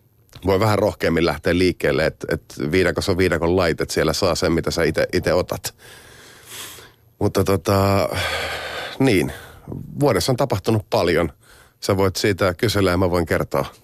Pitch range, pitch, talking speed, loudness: 95-115 Hz, 100 Hz, 145 wpm, -20 LUFS